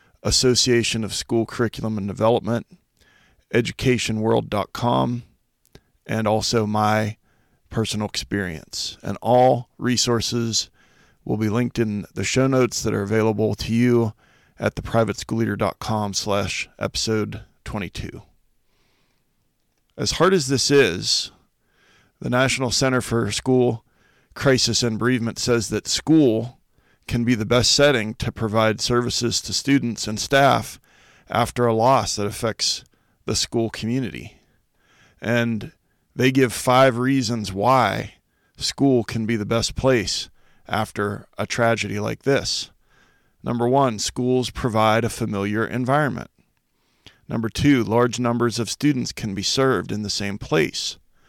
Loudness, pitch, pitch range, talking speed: -21 LUFS, 115 Hz, 105-125 Hz, 125 wpm